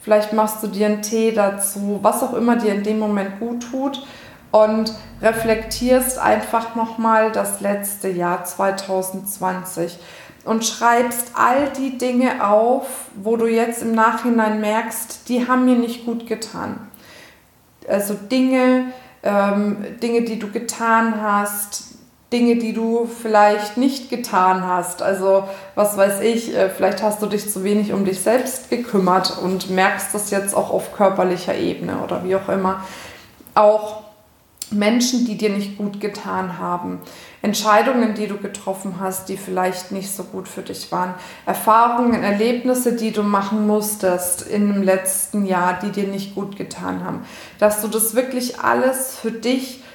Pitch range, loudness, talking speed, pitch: 195-235 Hz, -19 LUFS, 155 wpm, 210 Hz